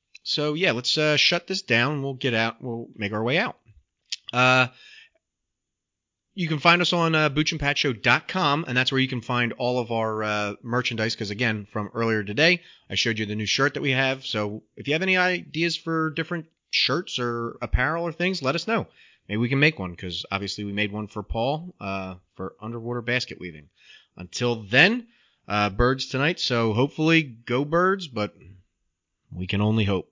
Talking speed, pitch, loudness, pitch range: 190 wpm, 125 Hz, -24 LUFS, 105-155 Hz